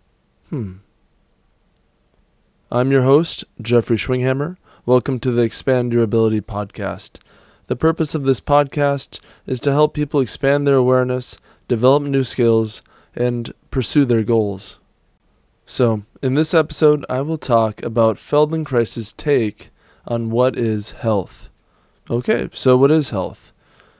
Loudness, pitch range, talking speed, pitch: -18 LUFS, 110-140 Hz, 130 wpm, 125 Hz